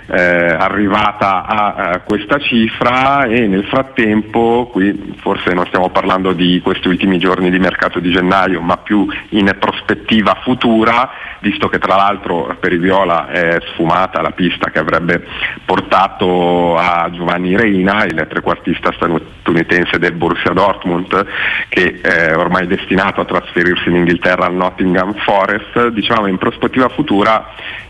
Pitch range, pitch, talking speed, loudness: 90-110 Hz, 95 Hz, 140 wpm, -13 LUFS